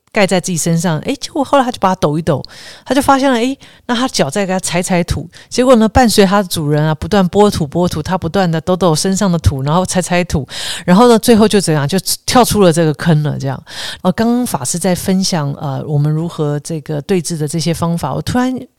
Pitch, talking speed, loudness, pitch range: 180 Hz, 345 characters per minute, -14 LUFS, 160-210 Hz